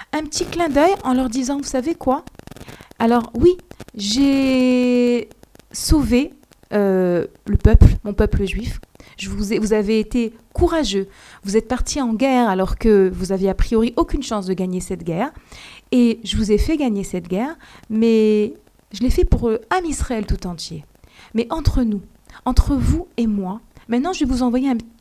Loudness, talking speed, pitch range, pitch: -19 LUFS, 180 wpm, 205-270 Hz, 235 Hz